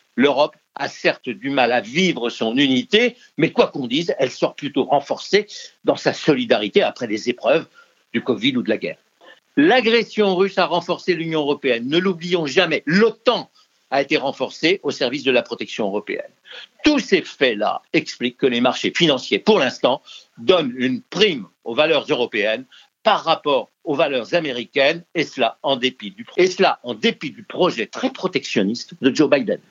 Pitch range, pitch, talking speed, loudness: 165-250 Hz, 195 Hz, 175 wpm, -19 LUFS